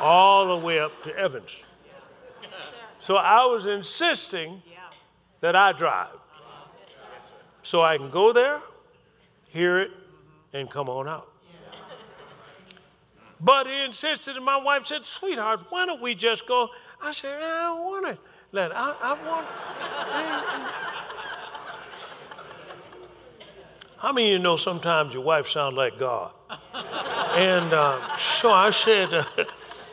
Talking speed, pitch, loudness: 130 wpm, 235 Hz, -23 LUFS